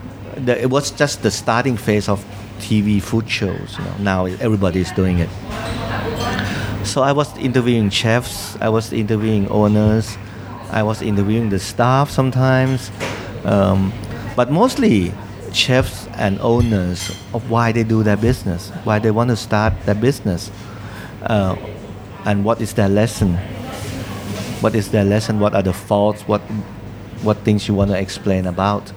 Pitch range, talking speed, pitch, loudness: 100-115 Hz, 150 wpm, 105 Hz, -18 LUFS